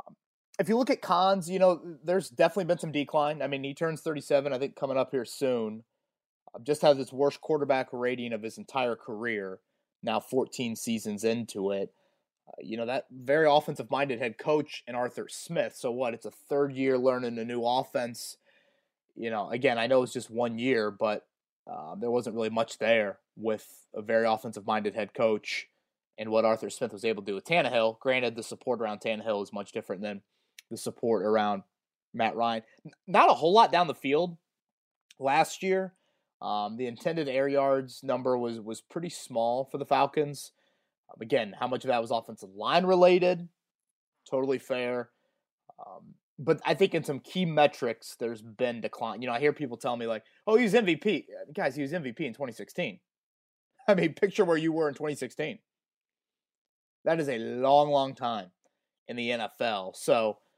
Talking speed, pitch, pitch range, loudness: 180 wpm, 135 Hz, 115-165 Hz, -29 LUFS